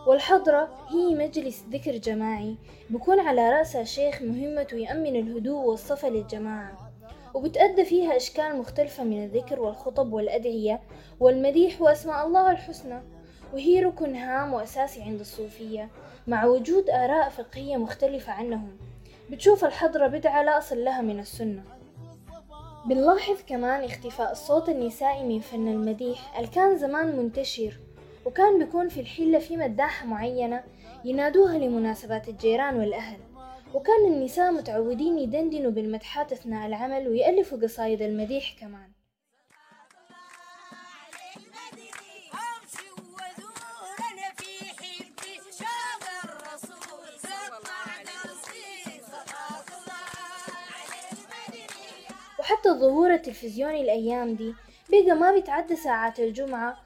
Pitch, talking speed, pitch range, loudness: 270 Hz, 95 wpm, 230-325 Hz, -25 LUFS